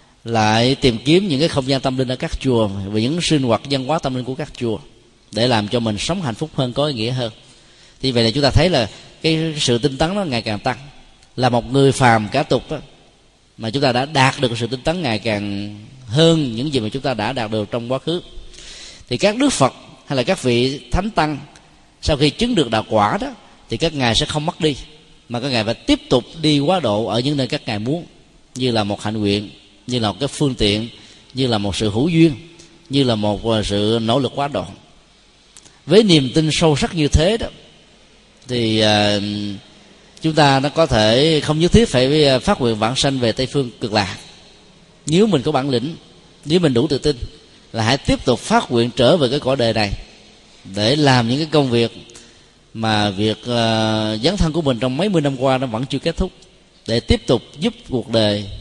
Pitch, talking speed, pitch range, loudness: 130 Hz, 230 wpm, 110-150 Hz, -18 LUFS